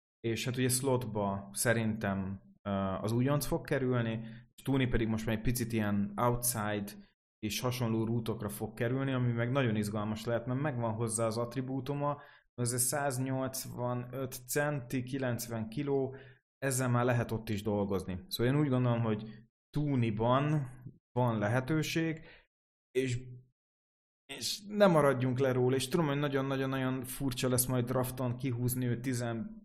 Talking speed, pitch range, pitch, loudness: 140 wpm, 110-135 Hz, 125 Hz, -33 LUFS